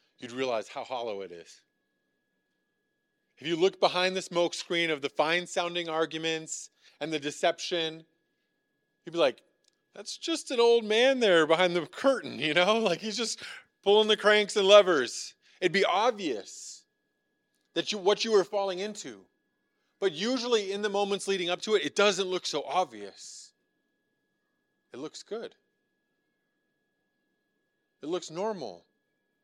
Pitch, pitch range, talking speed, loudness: 190 Hz, 170-215 Hz, 150 wpm, -27 LUFS